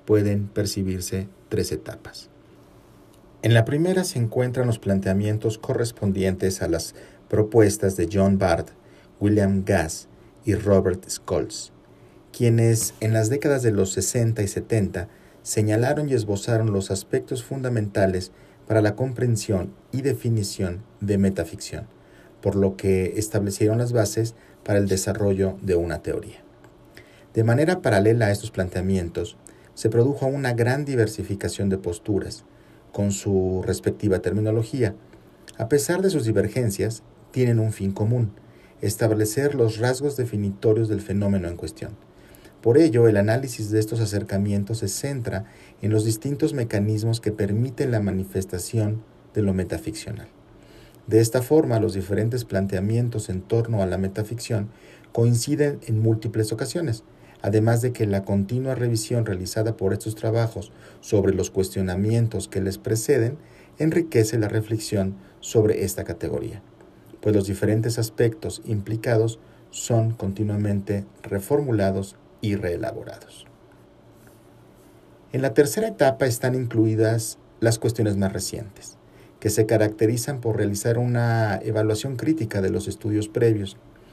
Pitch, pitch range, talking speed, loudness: 110 Hz, 100-115 Hz, 130 wpm, -23 LUFS